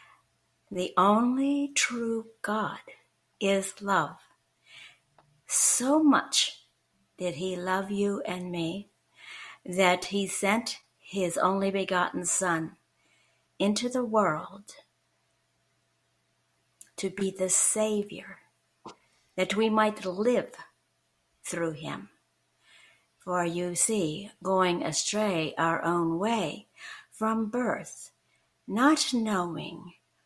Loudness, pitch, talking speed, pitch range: -28 LUFS, 195 Hz, 90 wpm, 180-220 Hz